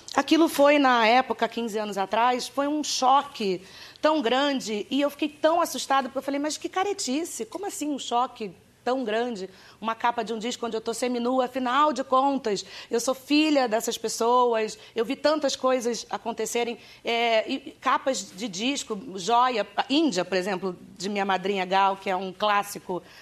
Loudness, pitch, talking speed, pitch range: -25 LUFS, 240 Hz, 175 wpm, 220-275 Hz